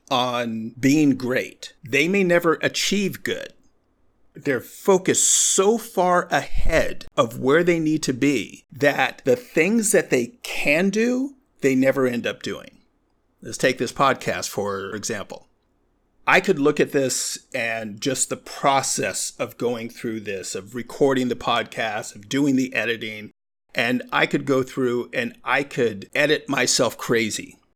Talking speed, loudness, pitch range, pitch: 150 wpm, -21 LUFS, 125-175 Hz, 135 Hz